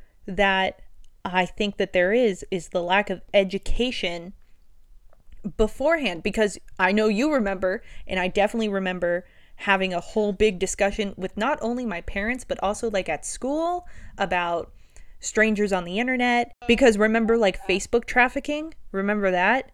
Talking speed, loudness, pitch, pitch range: 145 wpm, -24 LUFS, 205 Hz, 190-235 Hz